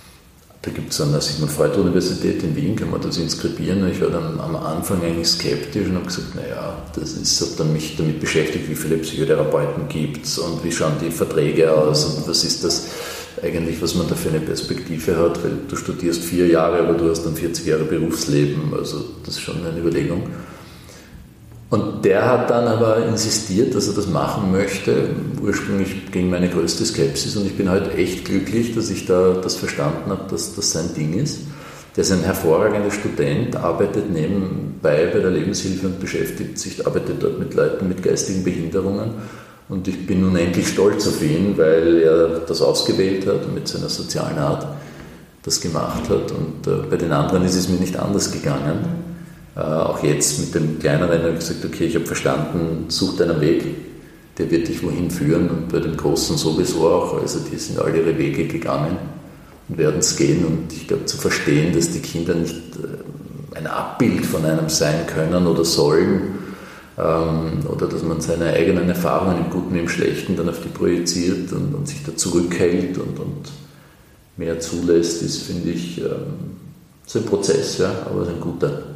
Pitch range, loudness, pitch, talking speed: 80-100 Hz, -20 LUFS, 90 Hz, 185 wpm